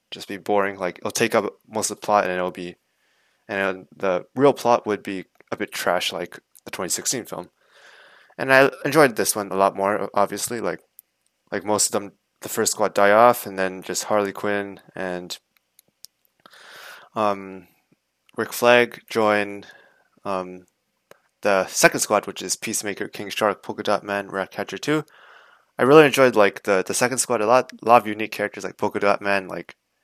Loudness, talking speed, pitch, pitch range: -21 LUFS, 180 wpm, 100 Hz, 95-120 Hz